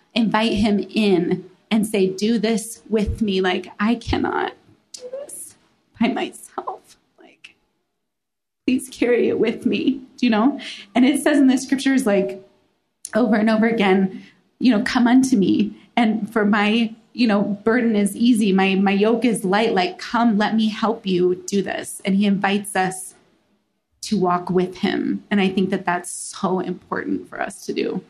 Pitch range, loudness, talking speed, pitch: 195-235 Hz, -20 LUFS, 175 wpm, 215 Hz